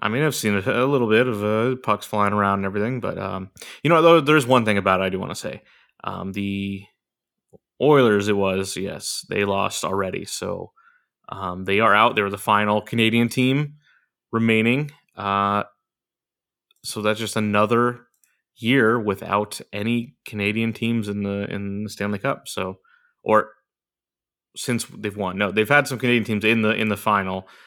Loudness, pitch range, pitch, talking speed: -21 LUFS, 100-120 Hz, 105 Hz, 175 wpm